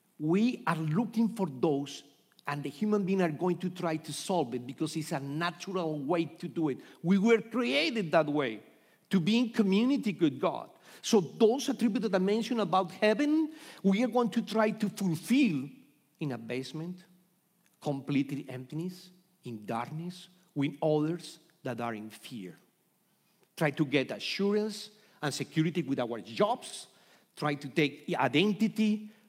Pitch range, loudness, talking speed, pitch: 150-215 Hz, -31 LUFS, 155 wpm, 180 Hz